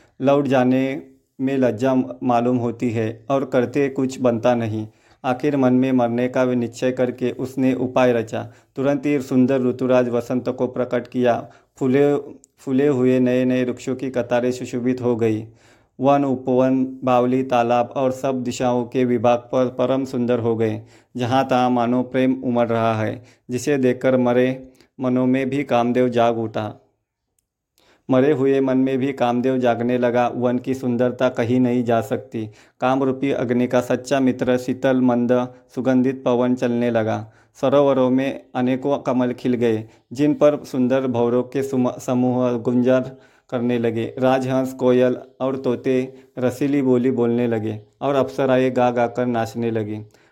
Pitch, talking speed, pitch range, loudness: 125 Hz, 150 wpm, 120-130 Hz, -20 LUFS